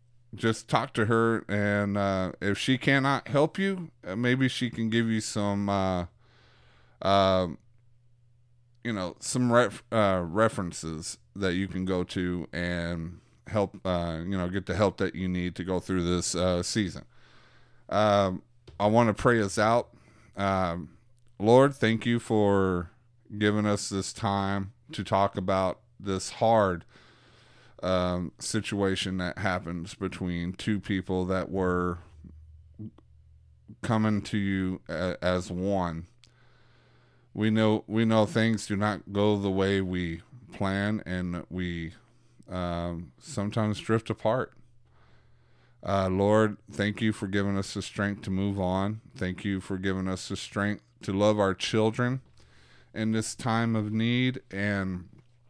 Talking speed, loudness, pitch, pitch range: 140 wpm, -28 LUFS, 100 Hz, 90-115 Hz